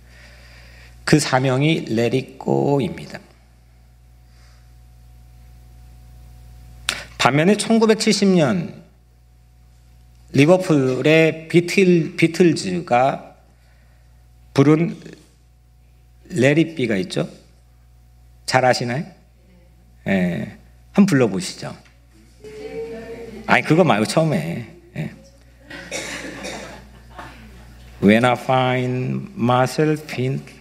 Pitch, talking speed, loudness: 65 Hz, 140 characters per minute, -18 LUFS